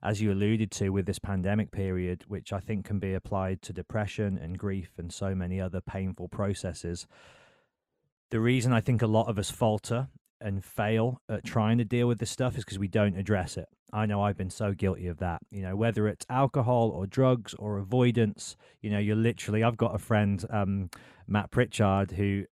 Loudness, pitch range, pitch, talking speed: -30 LUFS, 95-115 Hz, 105 Hz, 205 wpm